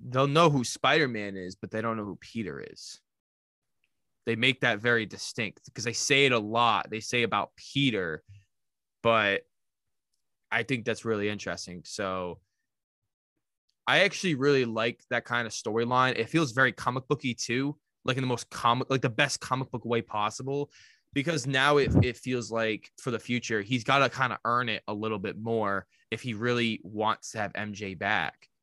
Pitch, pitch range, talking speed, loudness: 120 Hz, 110-130 Hz, 185 wpm, -28 LUFS